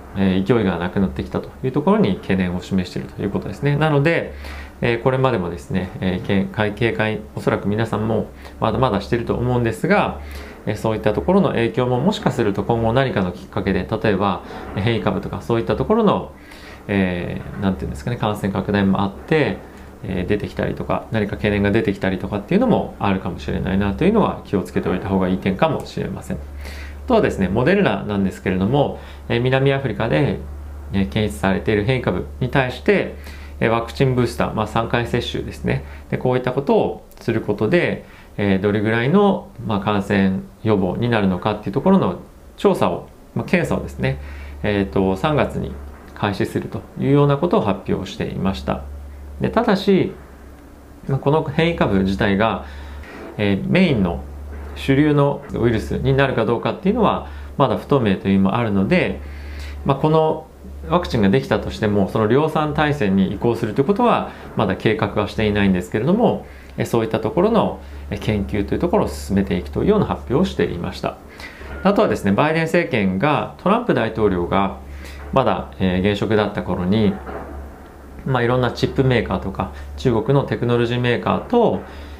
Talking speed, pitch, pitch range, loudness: 390 characters per minute, 100 Hz, 90-120 Hz, -20 LUFS